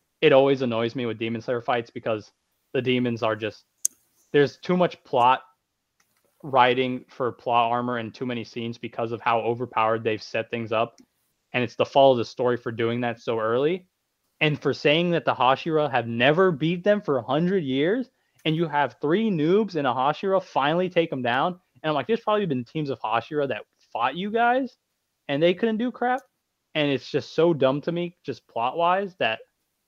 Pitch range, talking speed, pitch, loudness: 120-175 Hz, 200 wpm, 140 Hz, -24 LUFS